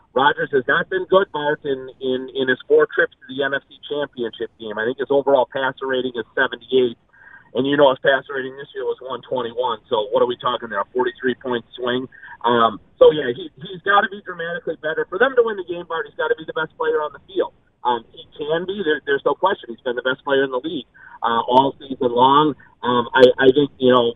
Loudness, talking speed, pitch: -20 LUFS, 245 wpm, 155 Hz